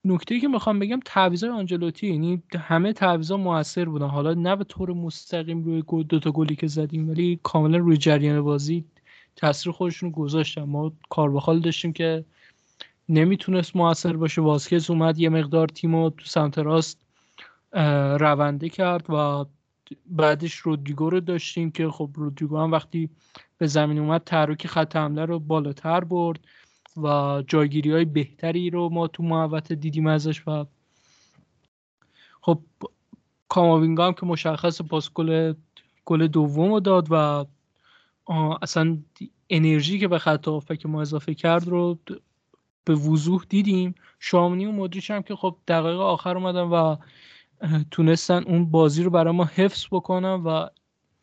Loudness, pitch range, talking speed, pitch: -23 LUFS, 155-175 Hz, 145 wpm, 165 Hz